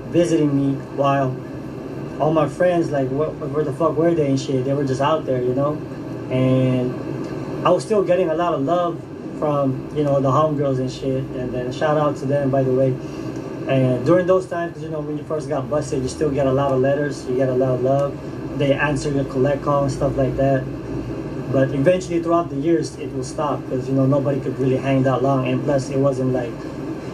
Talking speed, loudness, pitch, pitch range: 225 wpm, -20 LUFS, 140 Hz, 130-150 Hz